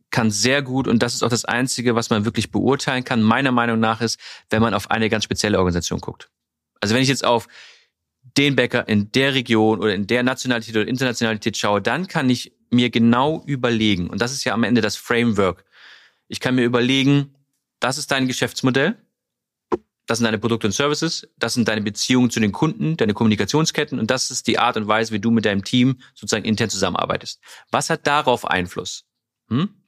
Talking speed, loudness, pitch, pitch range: 200 wpm, -20 LUFS, 120 Hz, 110-130 Hz